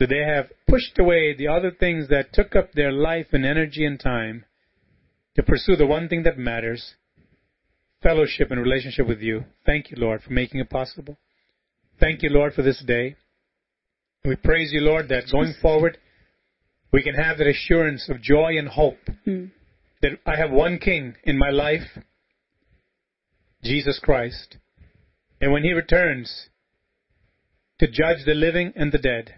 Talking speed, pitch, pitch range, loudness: 160 wpm, 150 Hz, 130-160 Hz, -22 LUFS